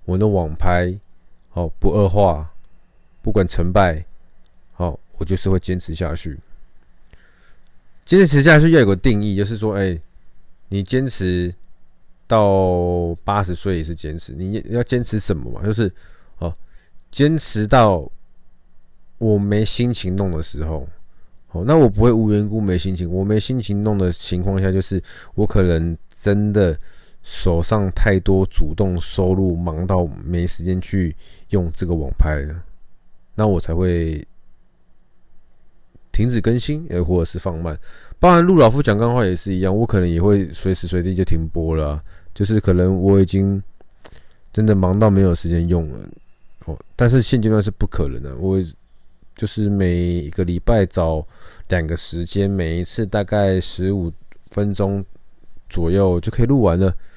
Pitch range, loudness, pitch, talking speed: 85-105 Hz, -18 LUFS, 95 Hz, 220 characters per minute